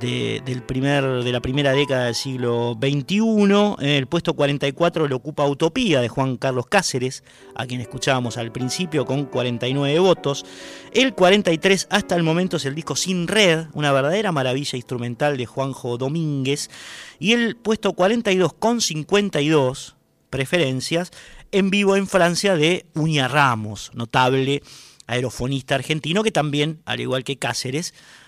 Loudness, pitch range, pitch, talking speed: -20 LUFS, 130-175 Hz, 140 Hz, 145 wpm